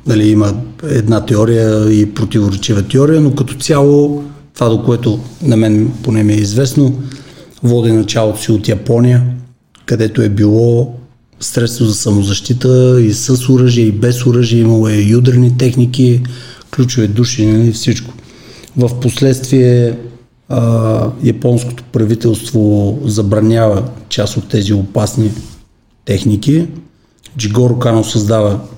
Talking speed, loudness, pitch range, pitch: 120 wpm, -12 LUFS, 110-125 Hz, 115 Hz